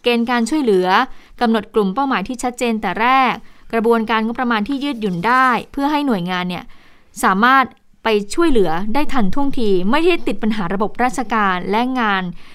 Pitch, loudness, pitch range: 235 Hz, -17 LUFS, 210-260 Hz